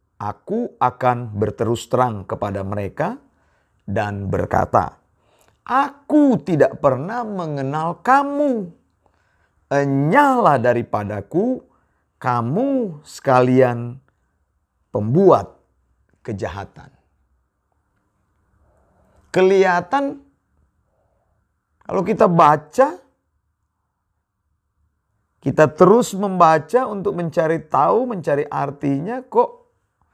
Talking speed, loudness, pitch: 65 wpm, -18 LUFS, 130 Hz